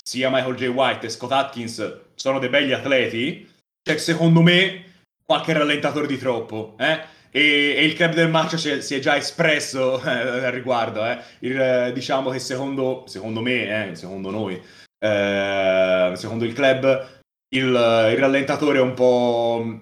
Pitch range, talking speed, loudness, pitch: 115-145 Hz, 165 wpm, -20 LUFS, 130 Hz